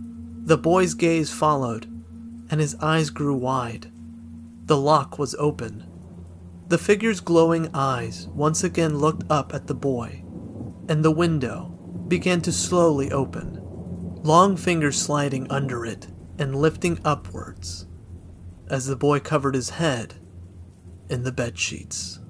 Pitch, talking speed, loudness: 130 Hz, 130 wpm, -23 LUFS